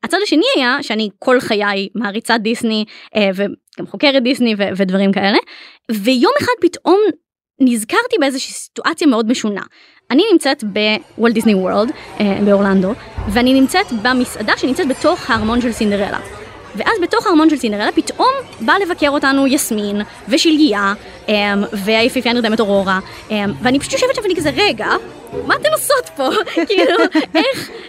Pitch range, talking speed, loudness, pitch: 210-315 Hz, 135 wpm, -15 LUFS, 245 Hz